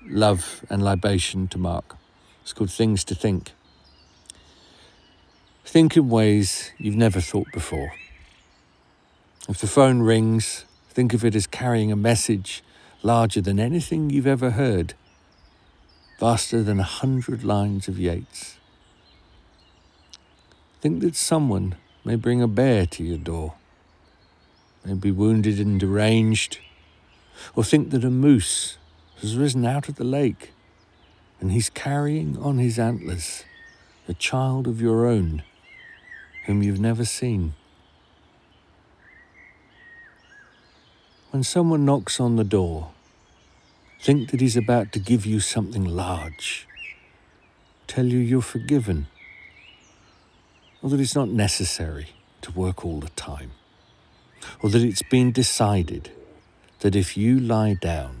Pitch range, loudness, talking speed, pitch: 85-120 Hz, -22 LUFS, 125 wpm, 100 Hz